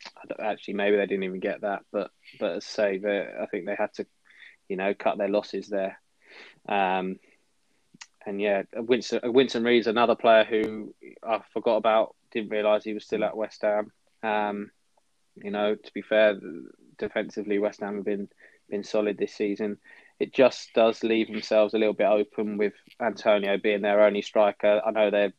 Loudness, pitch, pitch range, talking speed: -26 LUFS, 105 Hz, 100-110 Hz, 180 wpm